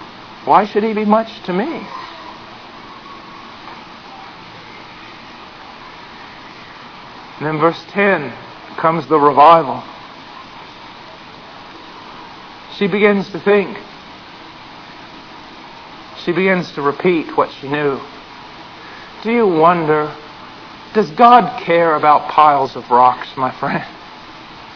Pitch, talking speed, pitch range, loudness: 170 Hz, 85 wpm, 150-205 Hz, -14 LUFS